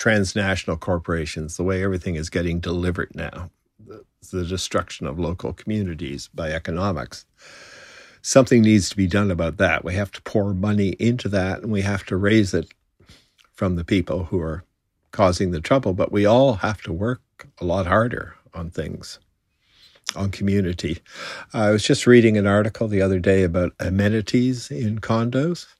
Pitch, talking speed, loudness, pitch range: 95 Hz, 165 wpm, -21 LUFS, 90-105 Hz